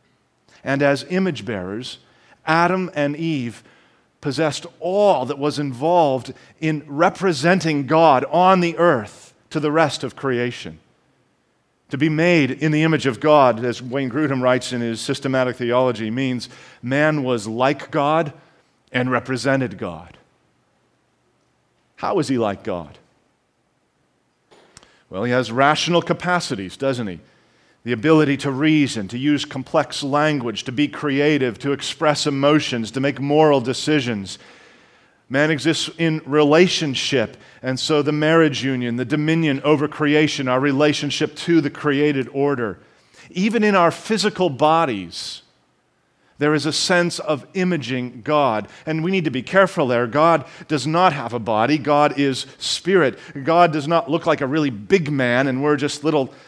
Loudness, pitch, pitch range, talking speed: -19 LUFS, 145 Hz, 130-160 Hz, 145 wpm